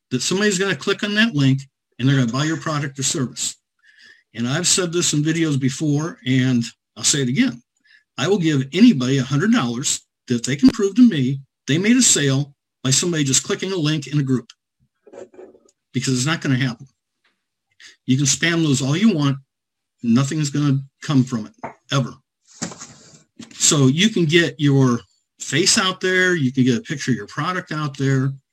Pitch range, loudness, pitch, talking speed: 130-170 Hz, -19 LUFS, 140 Hz, 185 wpm